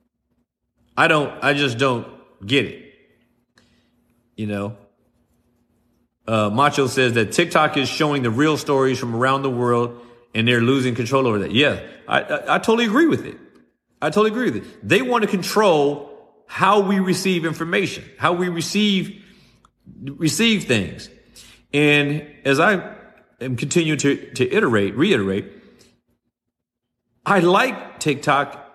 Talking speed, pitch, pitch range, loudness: 140 wpm, 140 Hz, 120-175 Hz, -19 LUFS